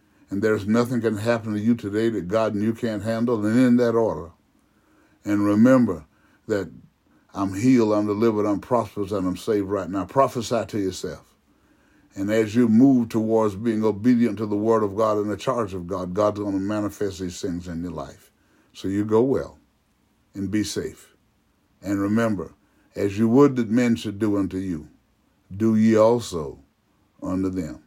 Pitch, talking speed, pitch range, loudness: 105 Hz, 180 wpm, 100-115 Hz, -22 LUFS